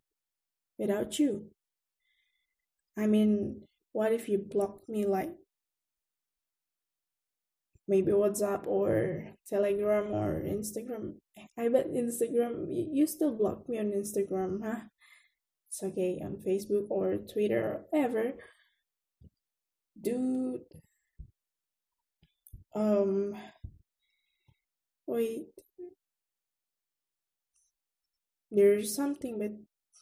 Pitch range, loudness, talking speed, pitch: 200-285 Hz, -31 LUFS, 80 wpm, 220 Hz